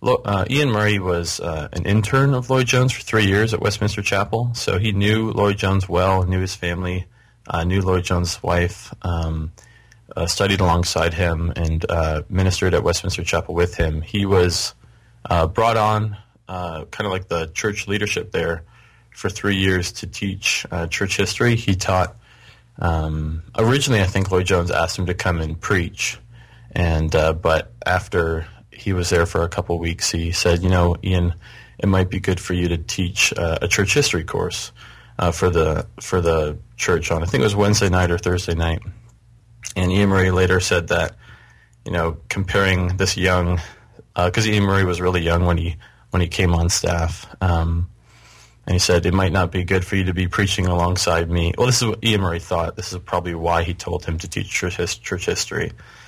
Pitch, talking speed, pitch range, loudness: 95 Hz, 195 wpm, 85-105 Hz, -20 LUFS